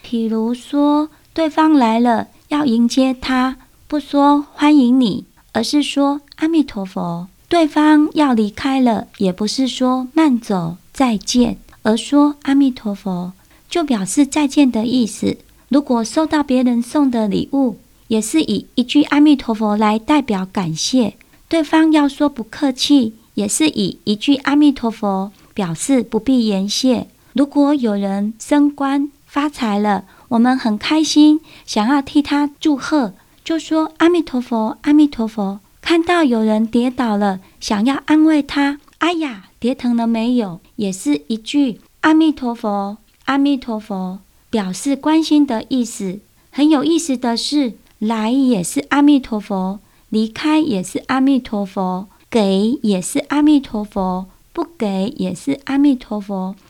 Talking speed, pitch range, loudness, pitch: 215 characters per minute, 215-290 Hz, -17 LUFS, 255 Hz